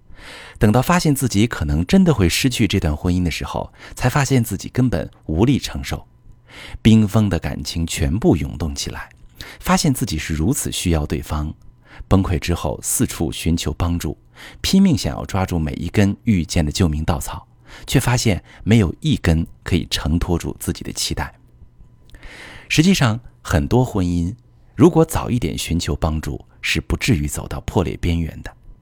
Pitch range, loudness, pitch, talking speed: 80-120 Hz, -19 LUFS, 90 Hz, 255 characters per minute